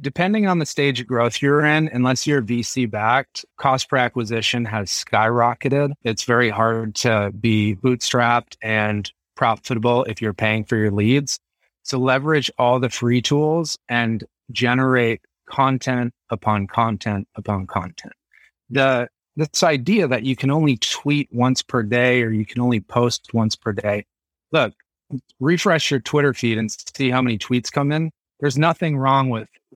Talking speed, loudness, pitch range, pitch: 160 wpm, -20 LUFS, 110-140 Hz, 125 Hz